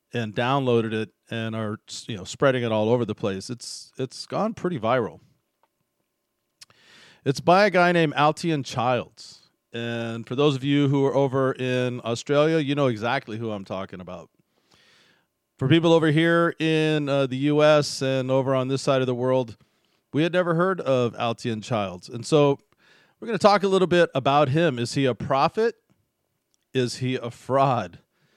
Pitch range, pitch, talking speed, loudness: 115-150 Hz, 135 Hz, 180 wpm, -23 LUFS